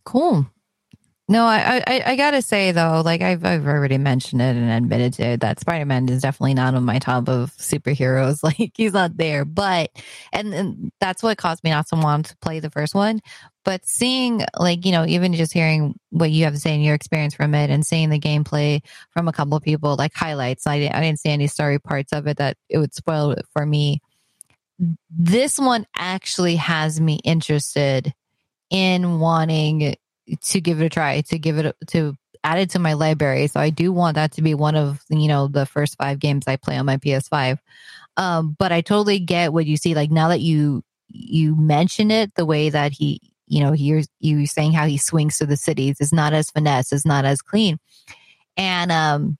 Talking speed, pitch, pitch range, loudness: 215 wpm, 155 Hz, 145-175 Hz, -20 LUFS